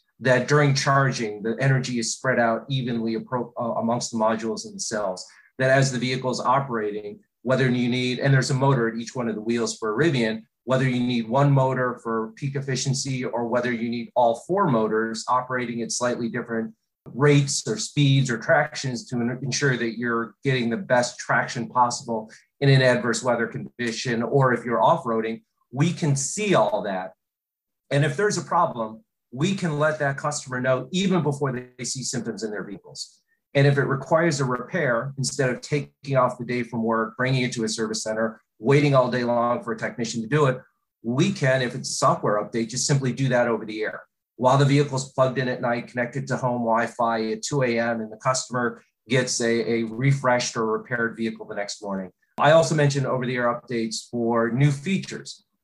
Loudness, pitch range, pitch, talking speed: -23 LUFS, 115-140 Hz, 125 Hz, 200 wpm